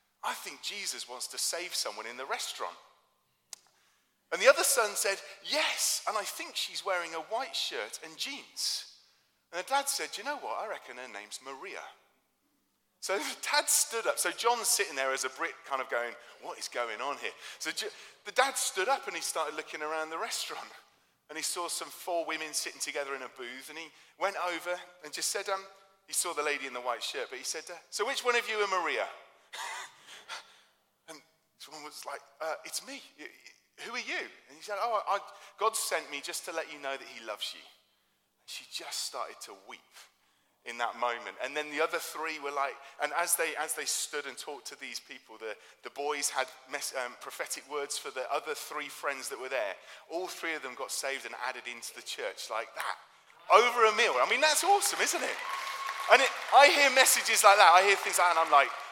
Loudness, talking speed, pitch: -30 LUFS, 215 wpm, 185 Hz